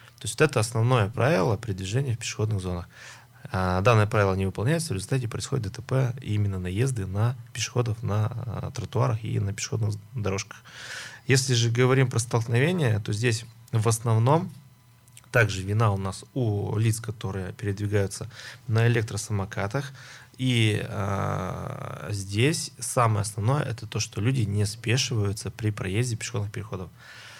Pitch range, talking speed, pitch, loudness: 105-125 Hz, 140 wpm, 115 Hz, -26 LUFS